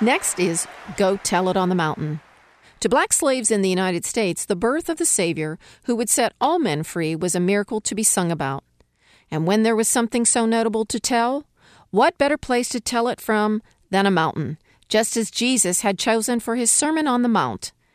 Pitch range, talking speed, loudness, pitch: 180-240 Hz, 210 wpm, -20 LUFS, 220 Hz